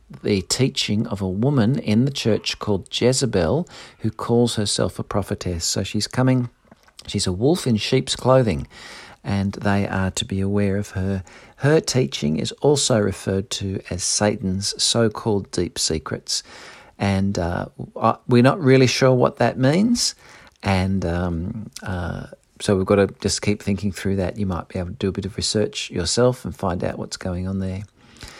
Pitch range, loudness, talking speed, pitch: 95-120 Hz, -21 LUFS, 175 wpm, 105 Hz